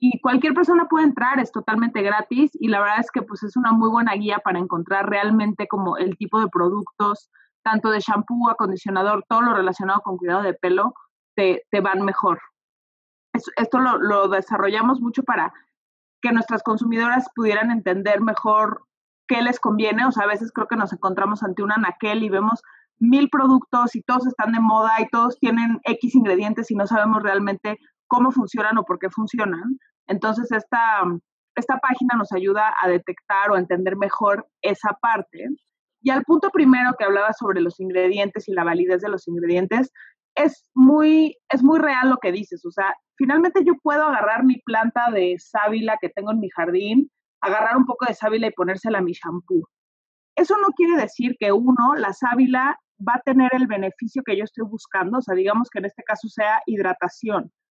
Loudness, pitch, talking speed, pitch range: -20 LUFS, 220 Hz, 185 wpm, 200-250 Hz